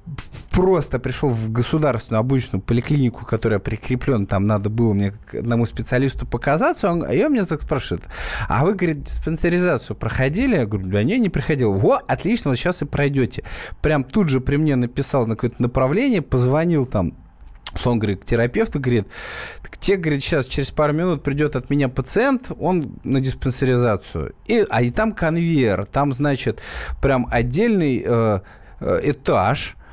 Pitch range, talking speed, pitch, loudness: 115-150 Hz, 155 wpm, 130 Hz, -20 LUFS